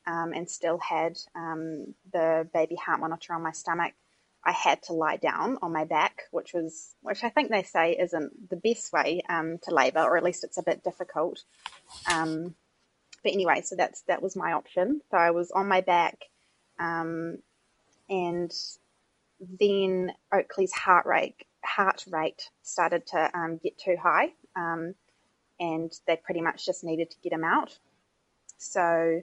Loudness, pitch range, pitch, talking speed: -28 LUFS, 165-185 Hz, 170 Hz, 170 wpm